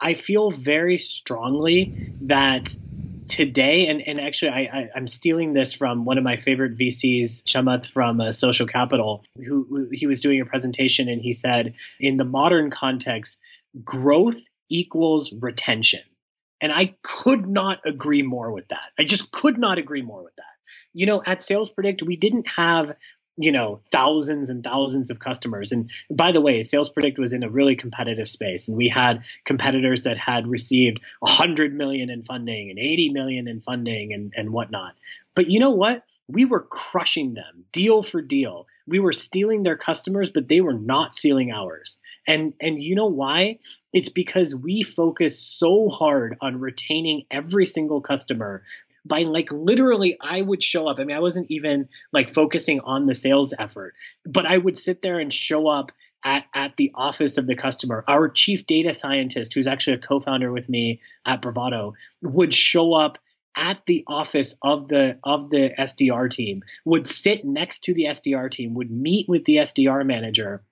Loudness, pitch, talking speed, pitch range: -21 LUFS, 140 Hz, 180 wpm, 125-170 Hz